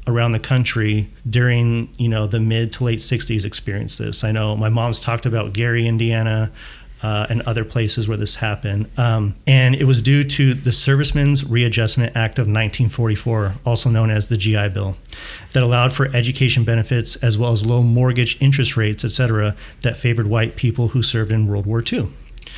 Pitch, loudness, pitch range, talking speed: 115 Hz, -18 LUFS, 110-120 Hz, 185 wpm